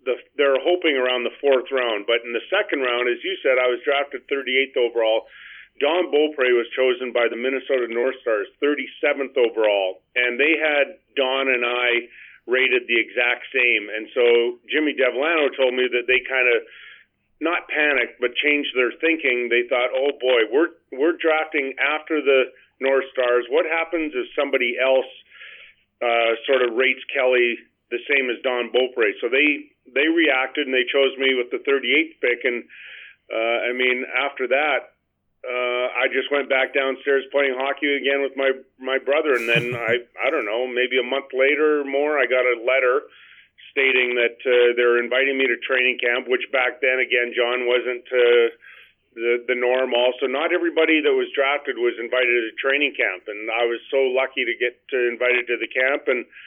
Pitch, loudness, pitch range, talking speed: 130 Hz, -20 LUFS, 125-145 Hz, 185 wpm